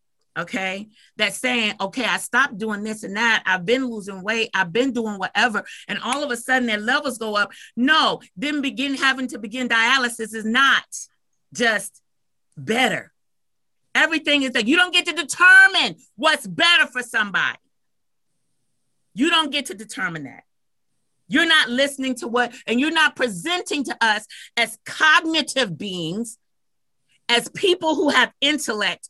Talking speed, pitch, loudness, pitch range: 155 wpm, 255 Hz, -19 LUFS, 220-295 Hz